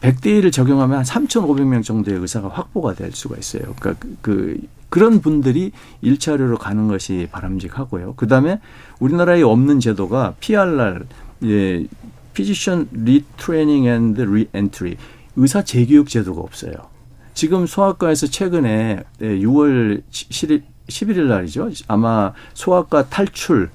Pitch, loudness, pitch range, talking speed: 125 Hz, -17 LUFS, 105-150 Hz, 325 characters per minute